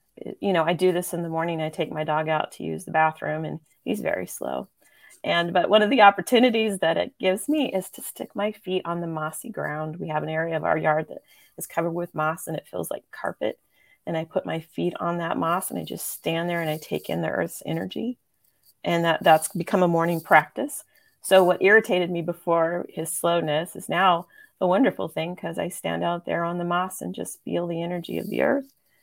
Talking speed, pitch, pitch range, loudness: 230 wpm, 170 Hz, 160-190 Hz, -24 LUFS